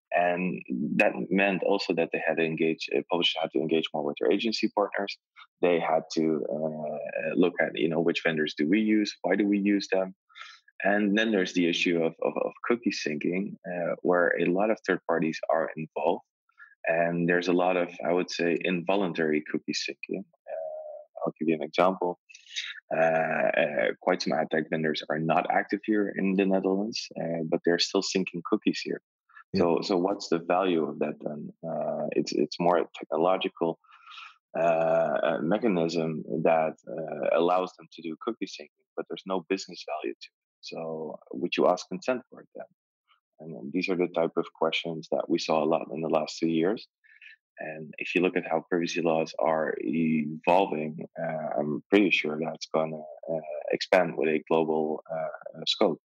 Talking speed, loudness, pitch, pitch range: 185 wpm, -28 LUFS, 85 Hz, 80-95 Hz